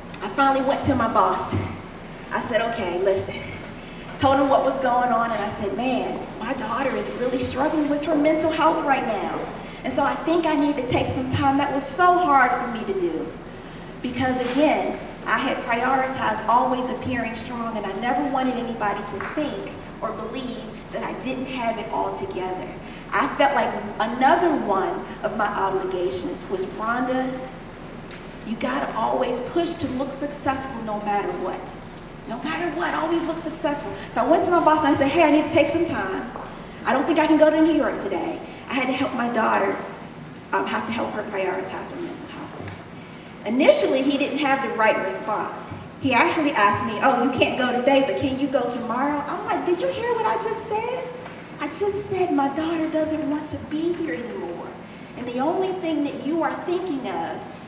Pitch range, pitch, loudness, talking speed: 235-310 Hz, 275 Hz, -23 LUFS, 200 wpm